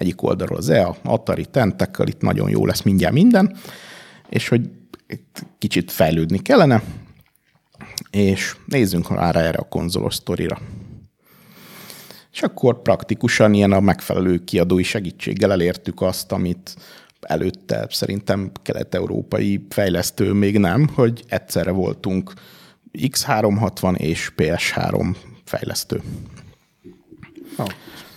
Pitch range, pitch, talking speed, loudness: 95-120 Hz, 100 Hz, 105 wpm, -19 LUFS